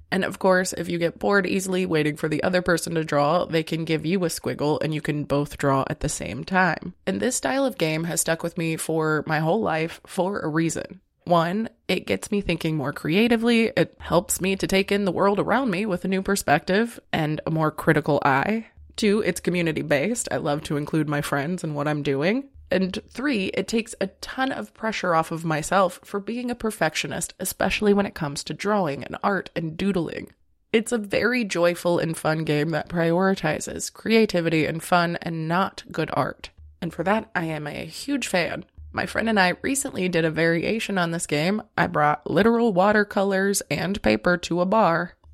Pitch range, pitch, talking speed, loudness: 155-200 Hz, 175 Hz, 205 wpm, -24 LUFS